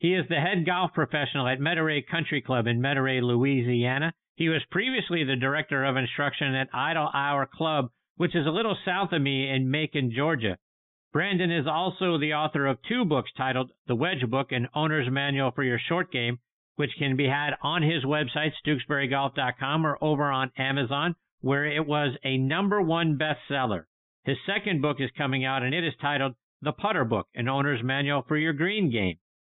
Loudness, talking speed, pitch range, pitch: -27 LUFS, 185 wpm, 130-160 Hz, 145 Hz